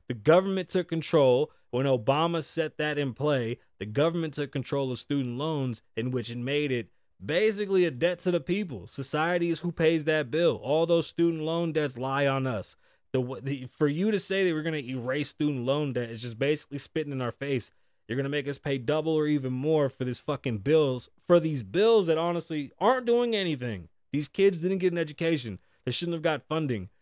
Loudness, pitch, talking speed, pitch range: -28 LUFS, 150 Hz, 215 wpm, 130-165 Hz